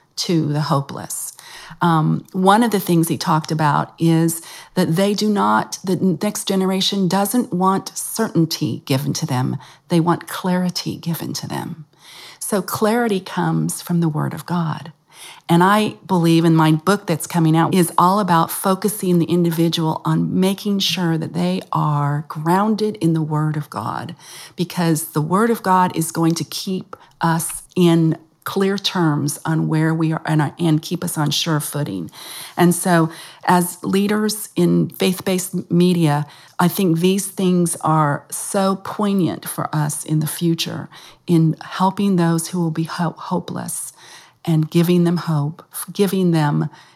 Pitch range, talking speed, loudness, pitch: 155-185 Hz, 155 wpm, -19 LUFS, 170 Hz